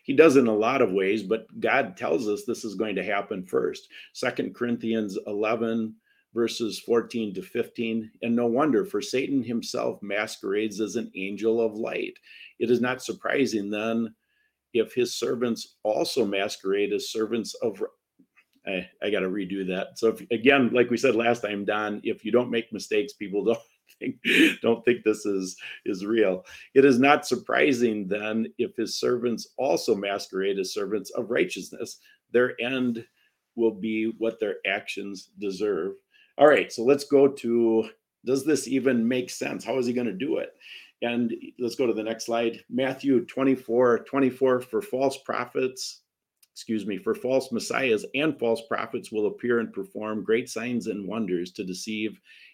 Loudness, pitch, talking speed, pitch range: -26 LUFS, 120 Hz, 170 wpm, 110-140 Hz